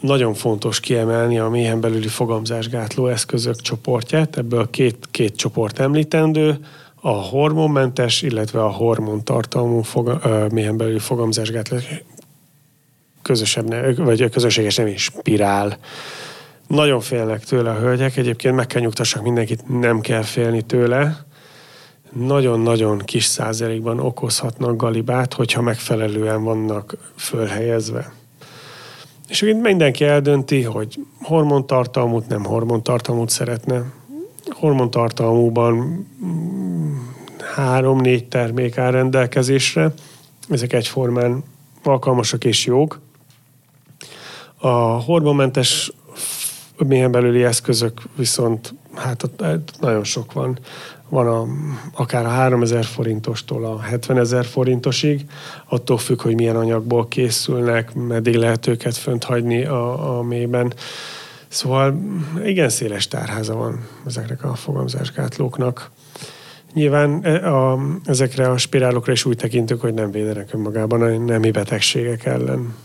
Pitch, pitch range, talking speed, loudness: 125 Hz, 115-140 Hz, 110 wpm, -19 LUFS